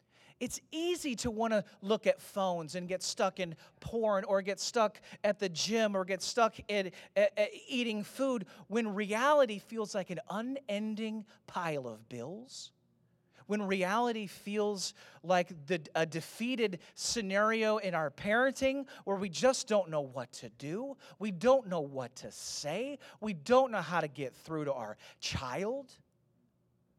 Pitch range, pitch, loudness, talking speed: 180-230 Hz, 205 Hz, -34 LUFS, 160 wpm